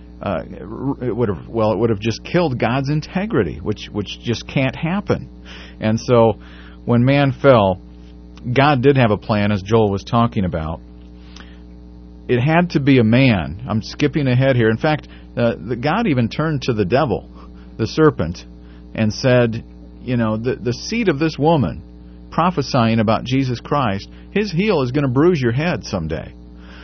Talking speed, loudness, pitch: 170 wpm, -18 LUFS, 115 Hz